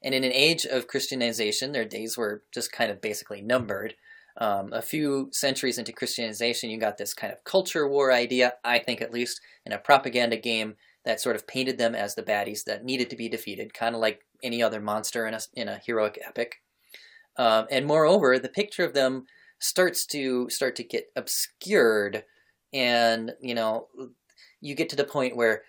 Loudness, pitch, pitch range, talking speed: -26 LUFS, 125 Hz, 115-140 Hz, 195 wpm